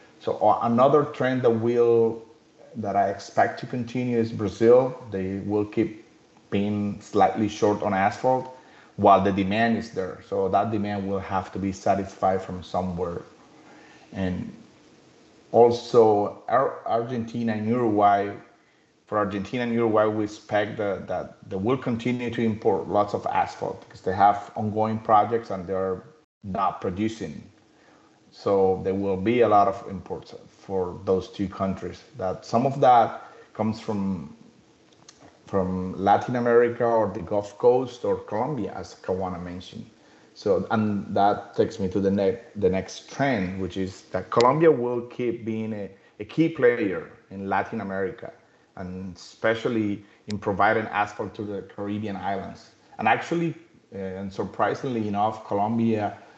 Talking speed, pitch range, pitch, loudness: 145 wpm, 95-115 Hz, 105 Hz, -24 LUFS